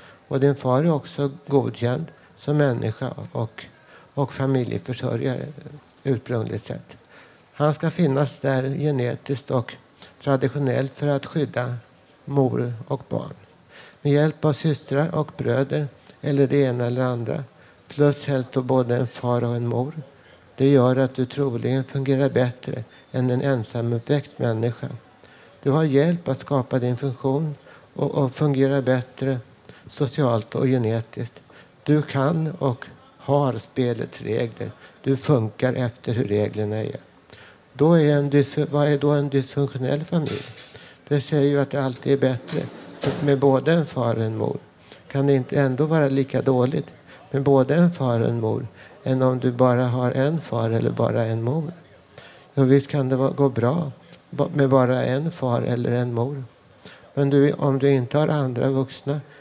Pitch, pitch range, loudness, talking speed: 135 Hz, 125-145 Hz, -23 LUFS, 155 wpm